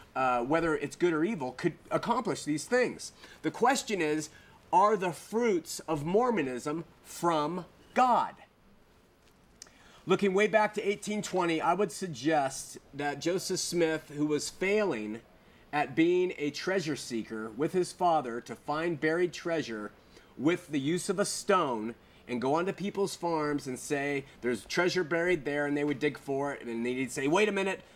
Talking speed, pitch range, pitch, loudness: 165 wpm, 145-190 Hz, 165 Hz, -30 LUFS